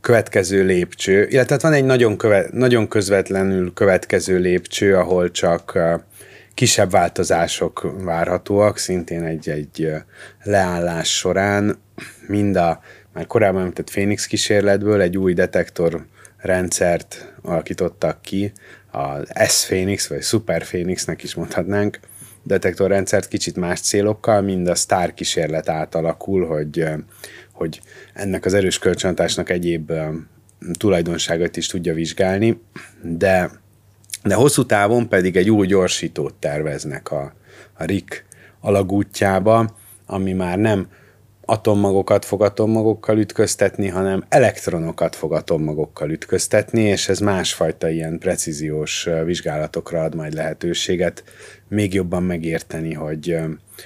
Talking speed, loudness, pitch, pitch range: 115 wpm, -19 LUFS, 95 Hz, 85-105 Hz